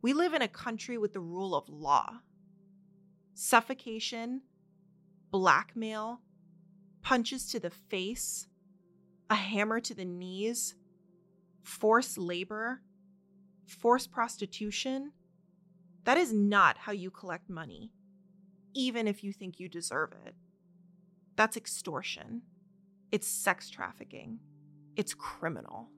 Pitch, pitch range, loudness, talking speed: 195 Hz, 185-220 Hz, -32 LUFS, 105 wpm